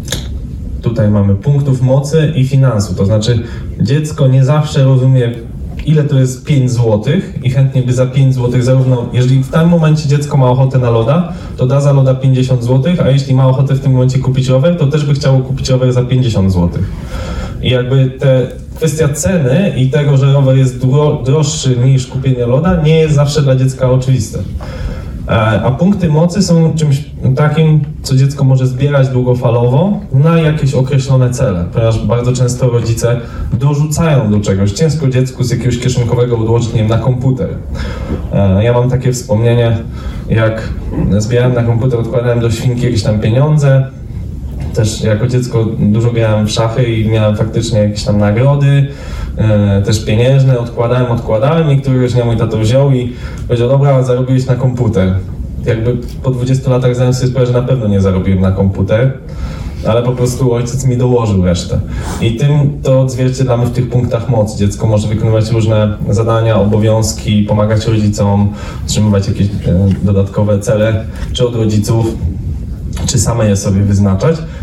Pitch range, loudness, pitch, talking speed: 110-135 Hz, -12 LUFS, 125 Hz, 160 wpm